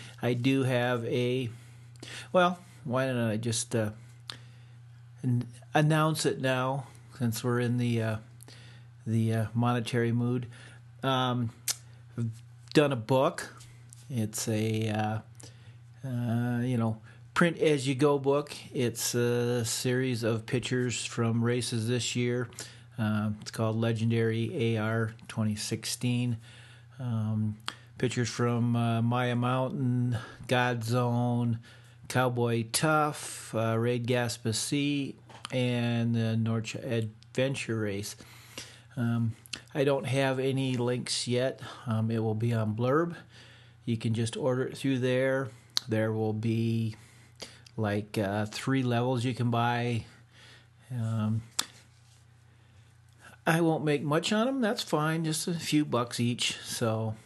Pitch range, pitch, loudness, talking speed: 115-125 Hz, 120 Hz, -30 LUFS, 125 wpm